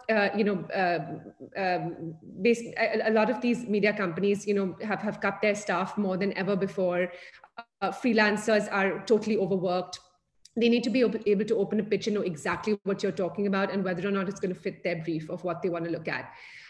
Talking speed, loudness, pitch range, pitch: 225 wpm, -28 LUFS, 180-215 Hz, 200 Hz